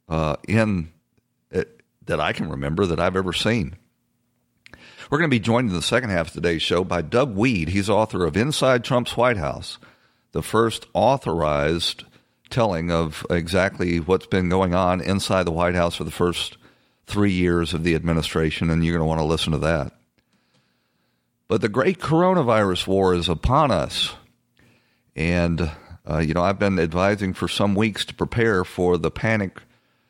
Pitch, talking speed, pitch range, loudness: 90 Hz, 175 wpm, 80-100 Hz, -22 LUFS